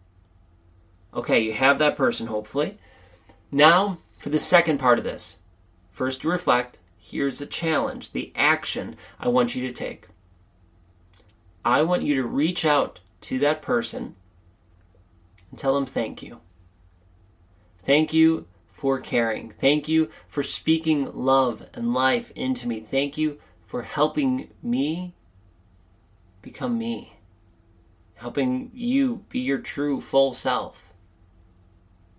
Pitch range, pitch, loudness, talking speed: 90-150 Hz, 115 Hz, -24 LUFS, 125 wpm